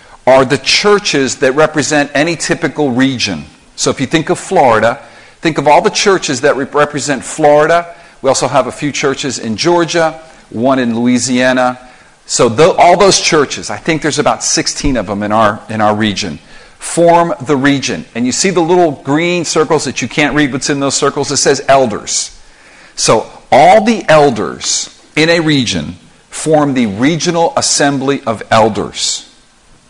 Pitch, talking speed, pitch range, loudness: 145 Hz, 170 wpm, 130-165 Hz, -11 LUFS